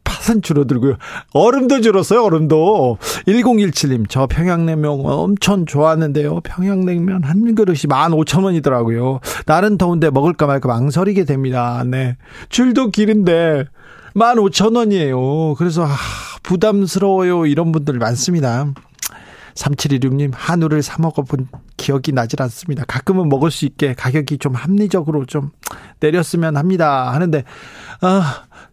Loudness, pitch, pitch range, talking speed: -15 LUFS, 155 Hz, 140-185 Hz, 280 characters per minute